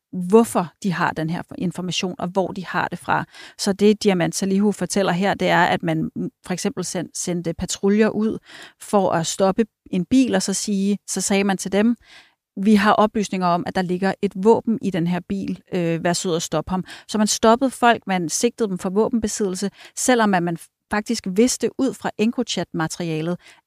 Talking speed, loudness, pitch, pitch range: 195 wpm, -21 LUFS, 195 Hz, 180-215 Hz